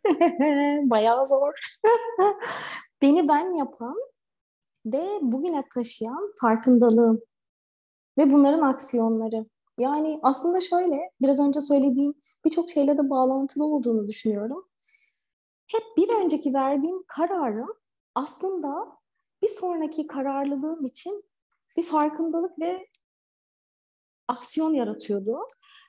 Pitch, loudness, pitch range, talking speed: 290 Hz, -24 LUFS, 260-355 Hz, 90 wpm